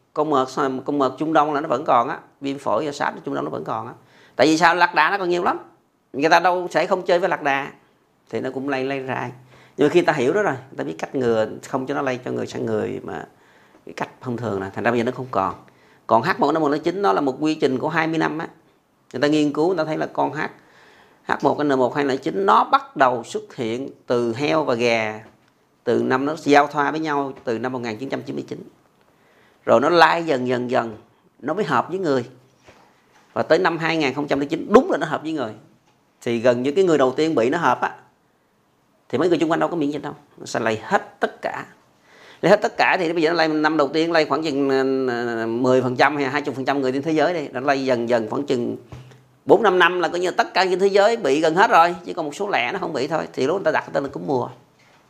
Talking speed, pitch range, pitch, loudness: 260 wpm, 130-160 Hz, 140 Hz, -20 LUFS